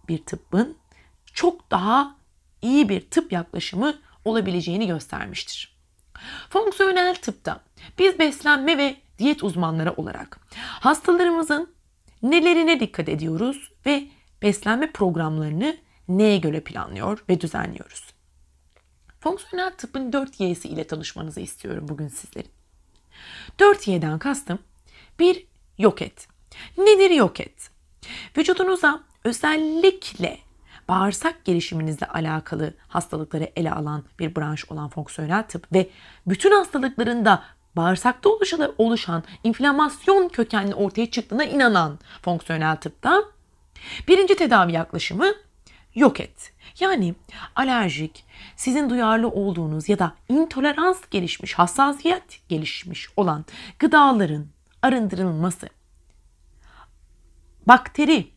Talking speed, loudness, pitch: 95 wpm, -21 LUFS, 210 Hz